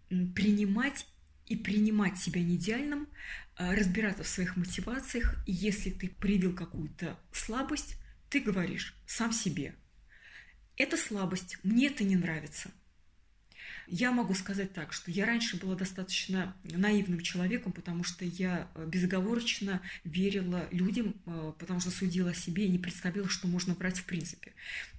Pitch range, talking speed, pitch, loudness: 175-205 Hz, 135 wpm, 185 Hz, -33 LUFS